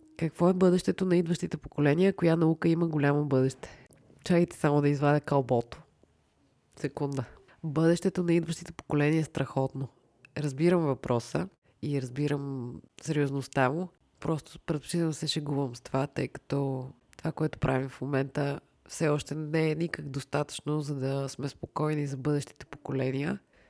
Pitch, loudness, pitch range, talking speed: 145 Hz, -30 LUFS, 135-165 Hz, 140 wpm